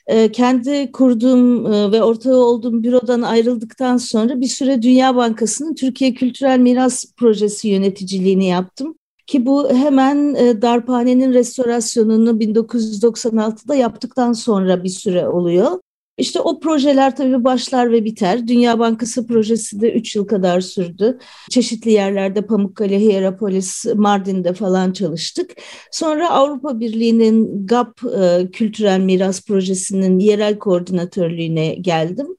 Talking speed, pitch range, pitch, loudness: 115 wpm, 200-250 Hz, 230 Hz, -16 LUFS